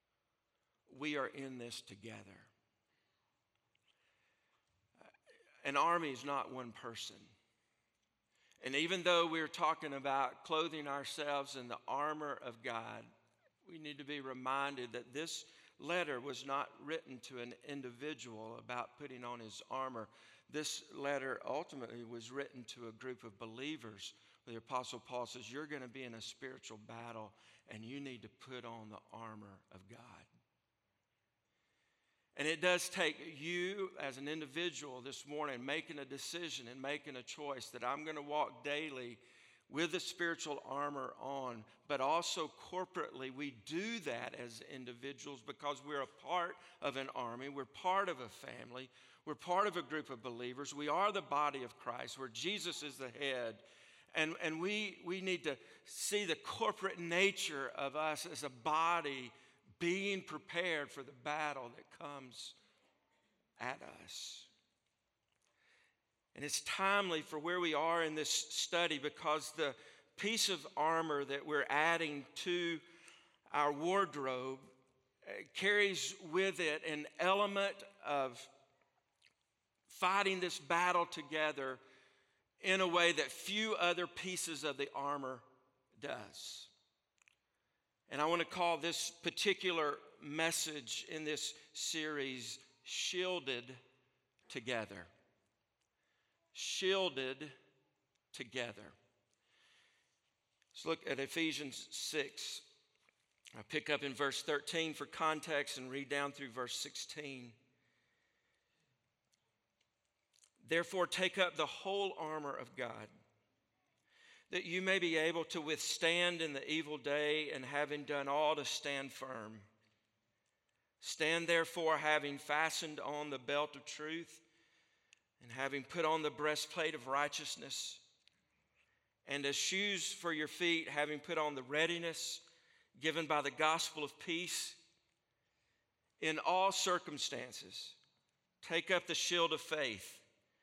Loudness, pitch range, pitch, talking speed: -39 LUFS, 130-170 Hz, 150 Hz, 130 wpm